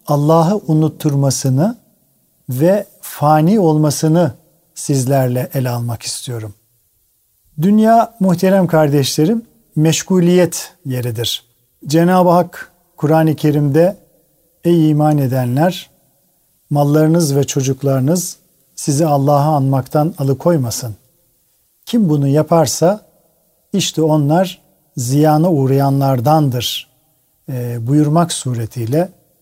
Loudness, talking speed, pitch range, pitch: -14 LUFS, 75 wpm, 135-170 Hz, 155 Hz